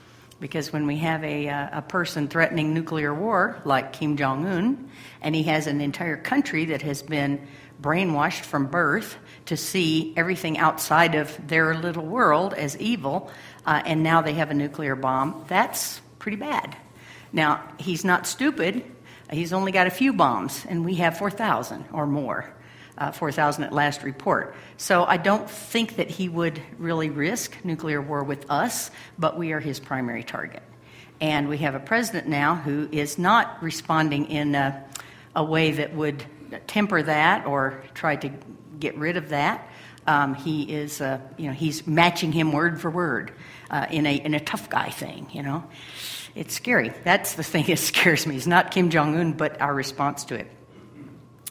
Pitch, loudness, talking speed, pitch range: 155 Hz, -24 LUFS, 175 wpm, 145-170 Hz